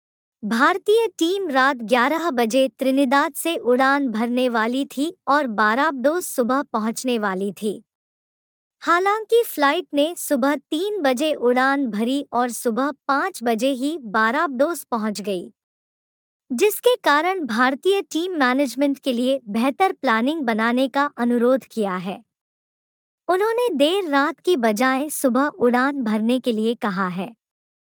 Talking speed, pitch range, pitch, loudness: 125 wpm, 240-305 Hz, 270 Hz, -20 LUFS